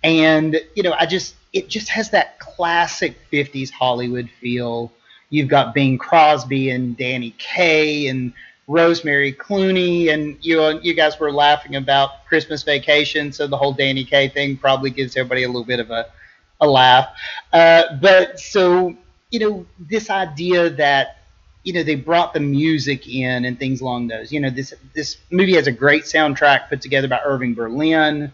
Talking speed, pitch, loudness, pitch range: 170 wpm, 145 Hz, -17 LUFS, 130-165 Hz